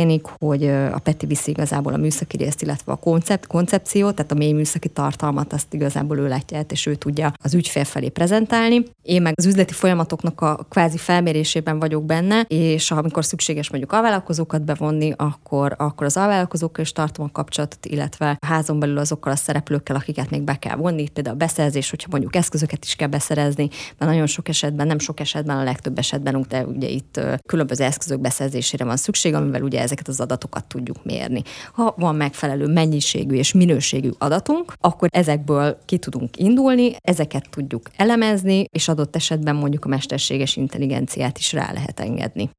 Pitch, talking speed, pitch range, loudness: 150 Hz, 175 wpm, 145-165 Hz, -20 LUFS